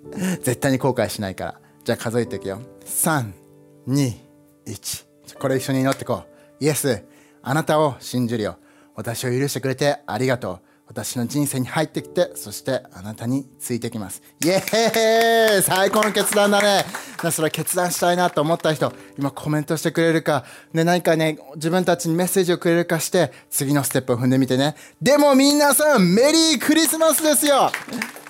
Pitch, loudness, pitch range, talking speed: 150 Hz, -20 LUFS, 125-180 Hz, 345 characters per minute